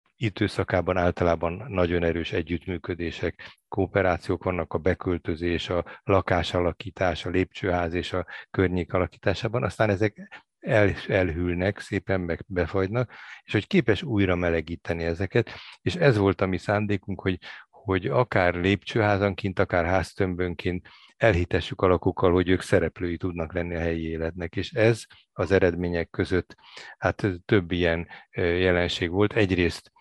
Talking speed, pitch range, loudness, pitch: 130 wpm, 85-100 Hz, -26 LUFS, 90 Hz